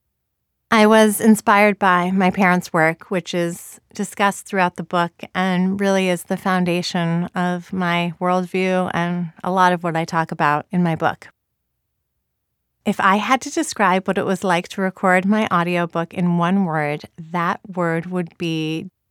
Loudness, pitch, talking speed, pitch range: -19 LUFS, 180 Hz, 165 wpm, 170-195 Hz